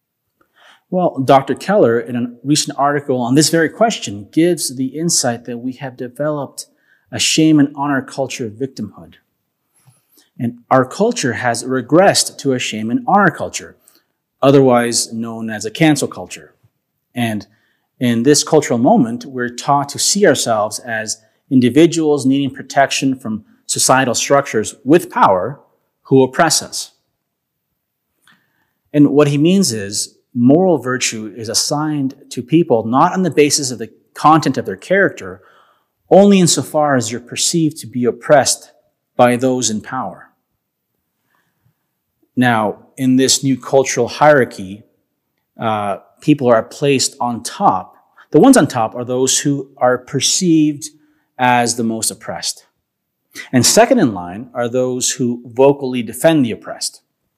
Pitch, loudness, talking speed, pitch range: 130 Hz, -15 LUFS, 140 wpm, 120-150 Hz